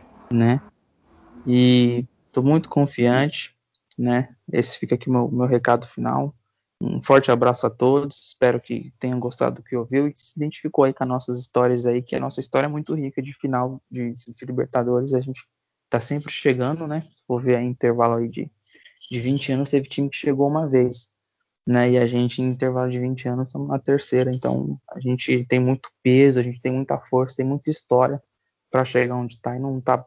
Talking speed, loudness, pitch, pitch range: 200 wpm, -22 LUFS, 125 Hz, 120-135 Hz